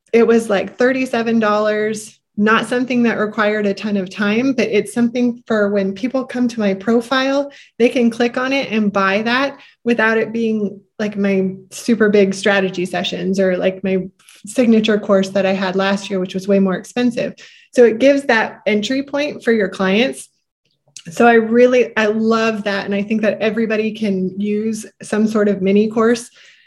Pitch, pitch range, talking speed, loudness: 215 Hz, 195-240 Hz, 180 wpm, -16 LUFS